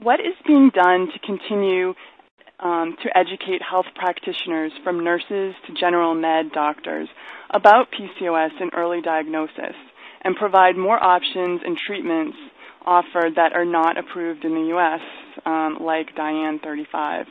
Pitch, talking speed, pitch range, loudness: 180 Hz, 140 wpm, 165-195 Hz, -20 LUFS